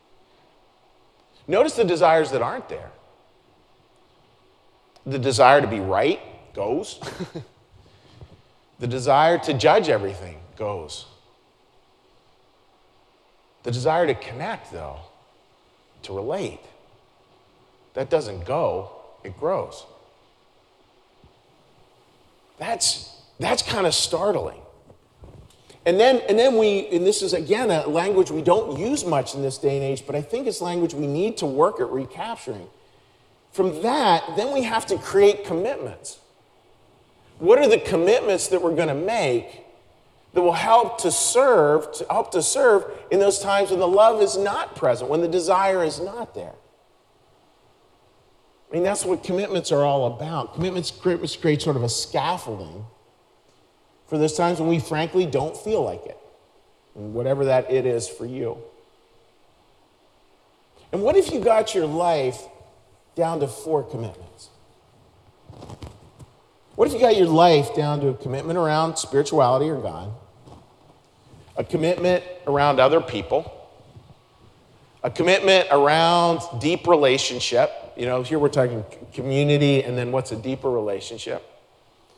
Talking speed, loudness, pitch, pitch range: 135 wpm, -21 LUFS, 155 Hz, 130-185 Hz